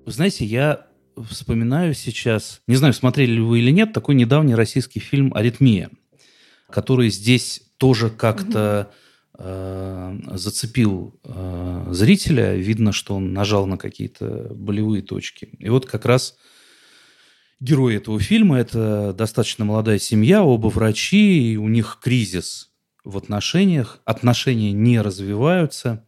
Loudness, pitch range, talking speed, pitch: -19 LUFS, 105-130 Hz, 125 wpm, 115 Hz